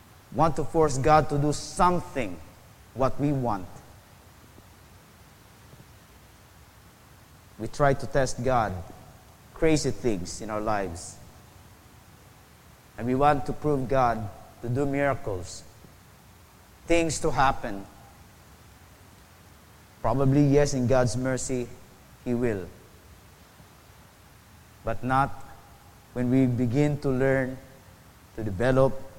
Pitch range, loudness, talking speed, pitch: 100-135 Hz, -26 LUFS, 100 wpm, 115 Hz